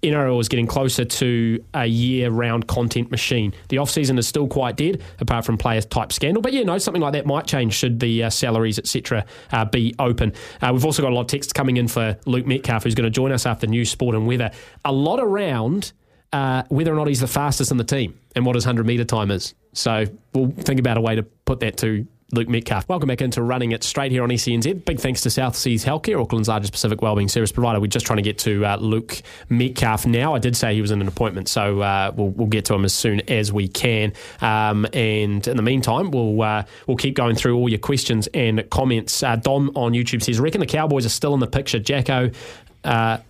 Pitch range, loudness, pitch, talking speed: 110-130 Hz, -20 LUFS, 120 Hz, 240 wpm